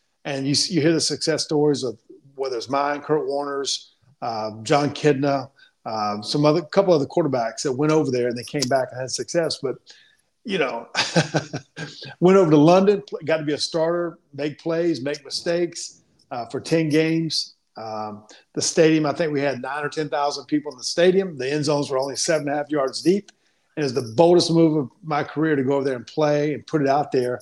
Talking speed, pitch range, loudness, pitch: 220 wpm, 135-160 Hz, -22 LUFS, 150 Hz